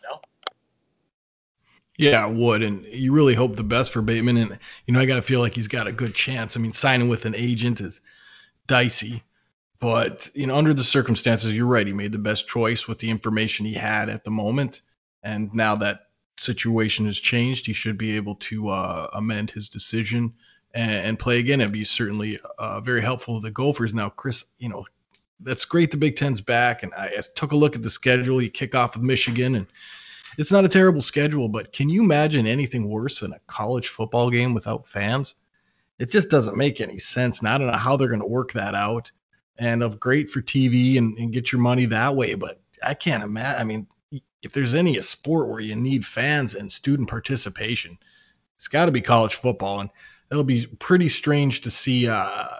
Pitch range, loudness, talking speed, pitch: 110-130 Hz, -22 LUFS, 210 wpm, 120 Hz